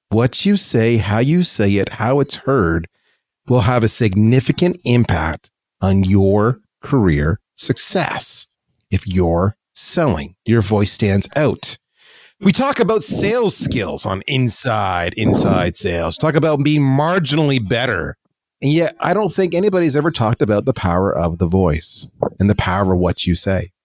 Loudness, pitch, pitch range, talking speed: -17 LUFS, 115 Hz, 95-150 Hz, 155 wpm